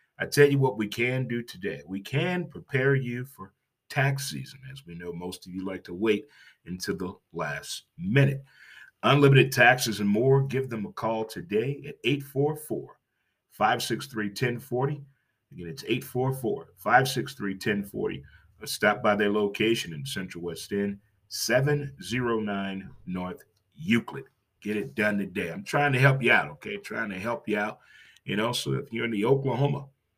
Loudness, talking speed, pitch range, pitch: -27 LUFS, 160 wpm, 100-140 Hz, 115 Hz